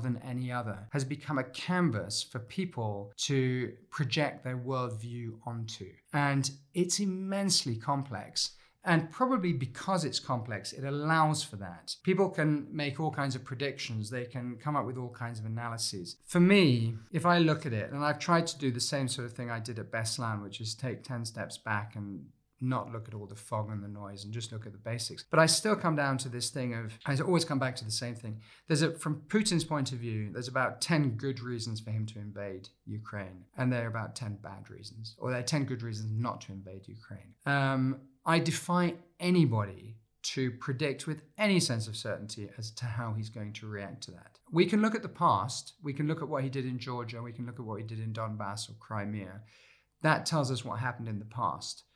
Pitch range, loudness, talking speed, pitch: 110-145 Hz, -32 LUFS, 220 wpm, 125 Hz